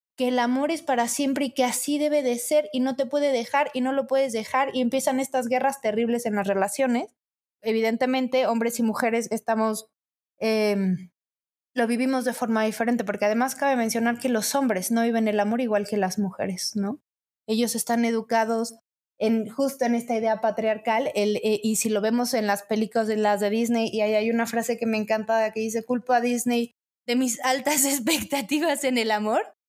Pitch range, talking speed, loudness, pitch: 220-260 Hz, 200 wpm, -24 LUFS, 235 Hz